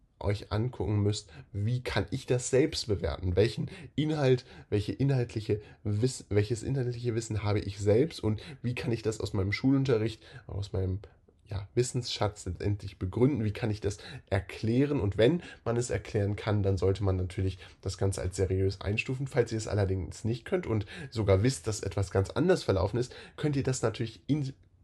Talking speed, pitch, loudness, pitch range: 180 wpm, 105 Hz, -31 LUFS, 100-125 Hz